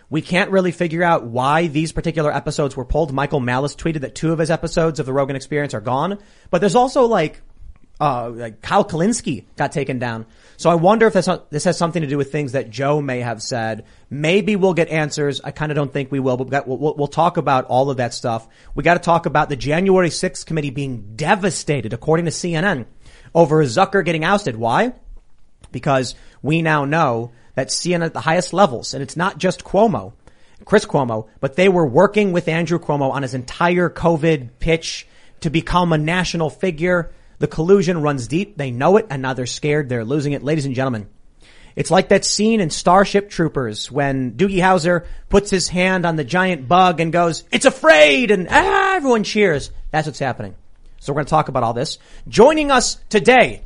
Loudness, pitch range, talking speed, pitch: -18 LUFS, 135-185 Hz, 205 wpm, 155 Hz